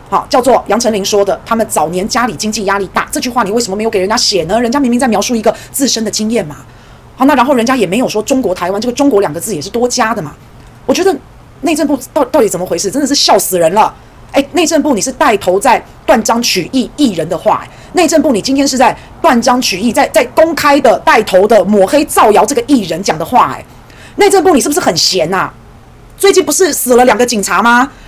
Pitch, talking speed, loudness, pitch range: 240 Hz, 355 characters per minute, -10 LUFS, 200-280 Hz